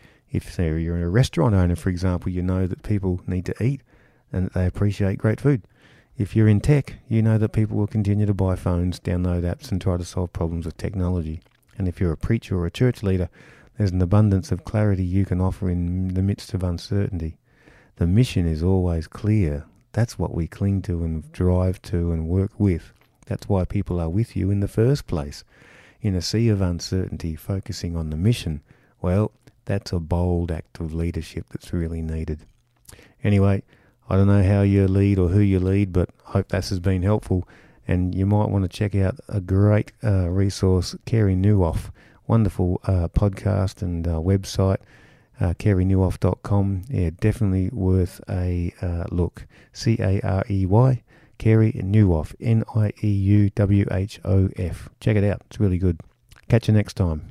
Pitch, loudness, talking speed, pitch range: 95 Hz, -23 LUFS, 175 wpm, 90-105 Hz